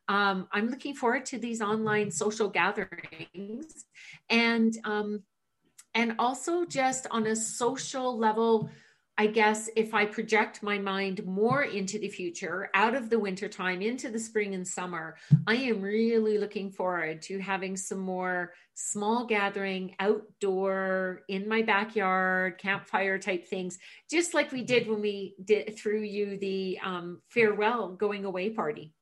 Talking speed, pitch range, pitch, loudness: 145 wpm, 190-225 Hz, 210 Hz, -29 LUFS